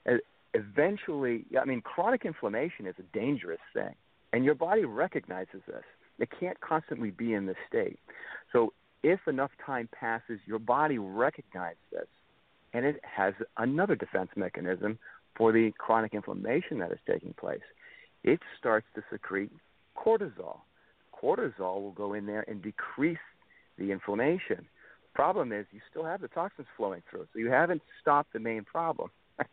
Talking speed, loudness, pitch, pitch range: 150 wpm, -32 LUFS, 115 Hz, 105-155 Hz